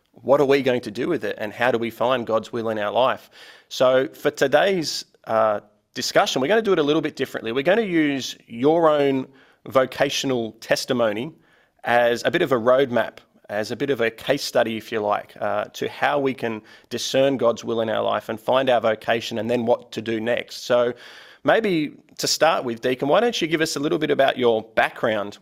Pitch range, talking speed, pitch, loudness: 115-140 Hz, 220 wpm, 125 Hz, -22 LUFS